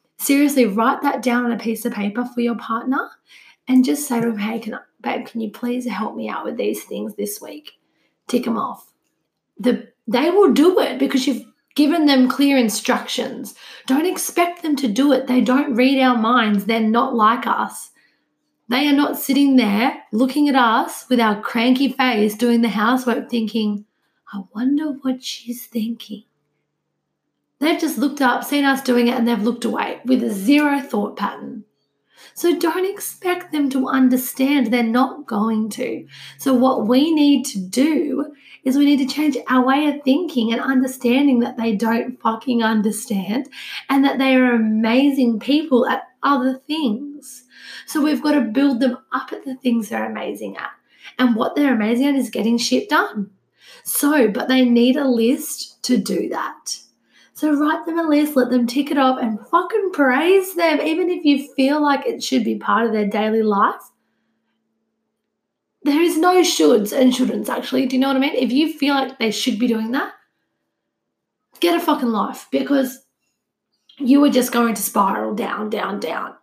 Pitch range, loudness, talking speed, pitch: 230-280 Hz, -18 LUFS, 185 wpm, 255 Hz